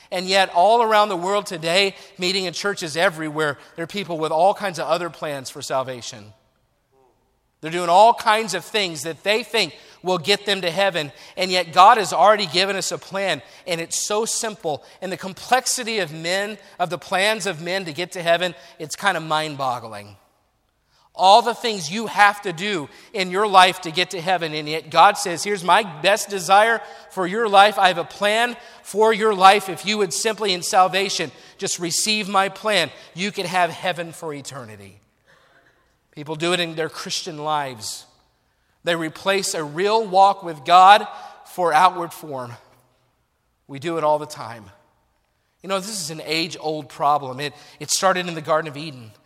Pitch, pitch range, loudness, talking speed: 180 Hz, 155-200 Hz, -20 LUFS, 190 wpm